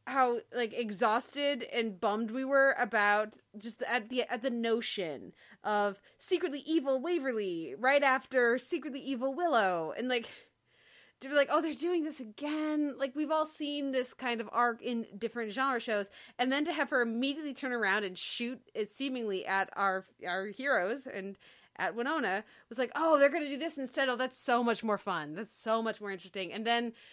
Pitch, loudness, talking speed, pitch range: 245 Hz, -32 LUFS, 190 wpm, 220-275 Hz